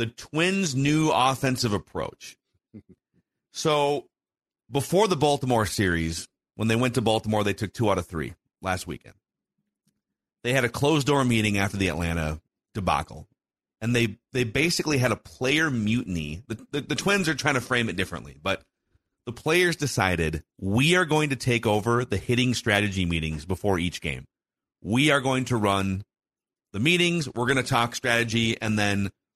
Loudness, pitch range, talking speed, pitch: -25 LUFS, 100-135 Hz, 170 wpm, 115 Hz